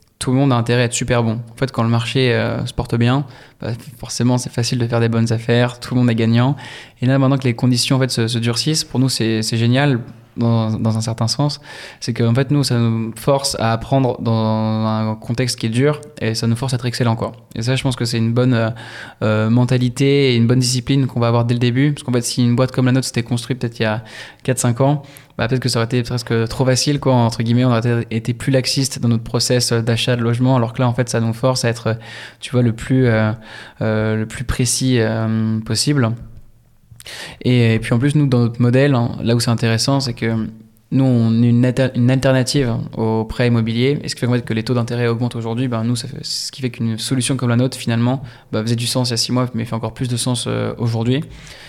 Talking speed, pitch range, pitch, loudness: 260 wpm, 115-130 Hz, 120 Hz, -17 LUFS